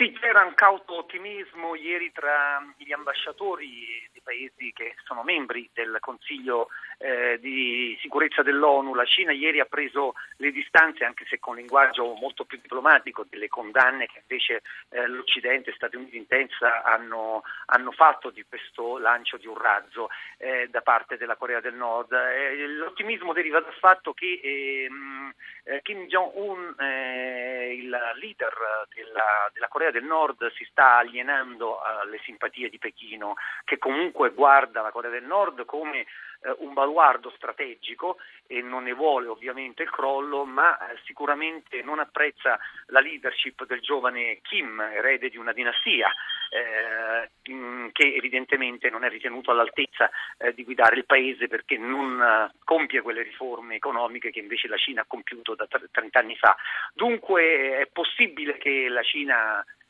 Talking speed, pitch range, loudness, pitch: 150 wpm, 125-160 Hz, -24 LUFS, 135 Hz